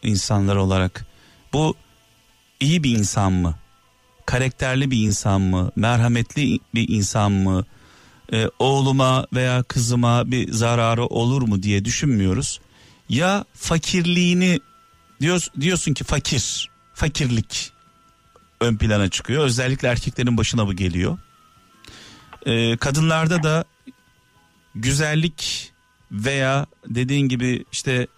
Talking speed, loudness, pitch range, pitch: 100 wpm, -20 LUFS, 105-140 Hz, 120 Hz